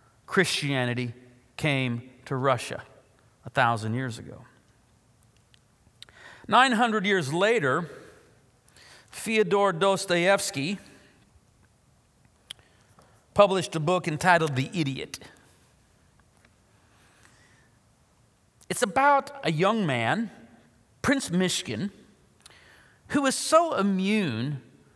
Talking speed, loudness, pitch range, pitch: 70 wpm, -25 LUFS, 125-200 Hz, 160 Hz